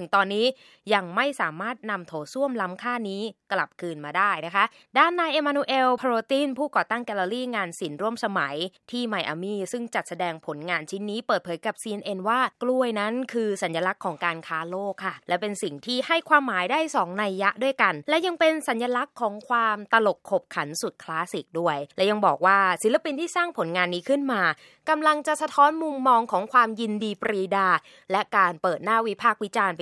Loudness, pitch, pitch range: -25 LUFS, 215 Hz, 185-255 Hz